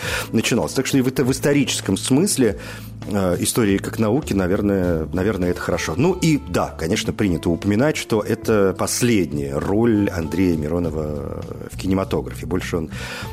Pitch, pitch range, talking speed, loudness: 100 Hz, 90-115 Hz, 150 wpm, -20 LUFS